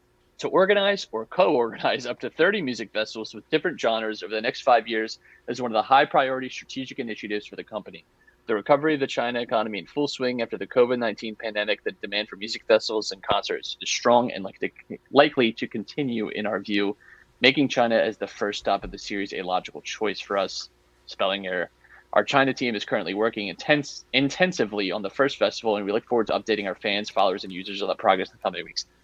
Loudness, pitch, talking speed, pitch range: -25 LUFS, 115 Hz, 215 wpm, 105-135 Hz